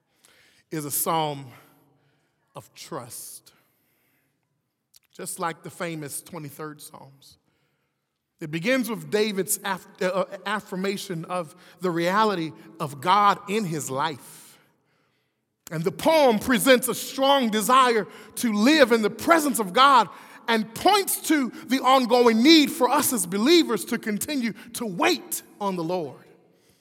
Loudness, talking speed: -22 LUFS, 130 wpm